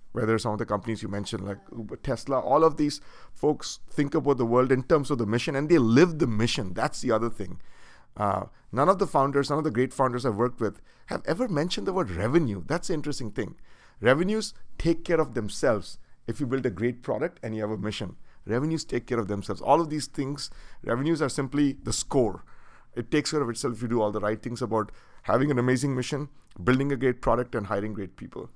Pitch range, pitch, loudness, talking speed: 110-150 Hz, 125 Hz, -27 LUFS, 230 wpm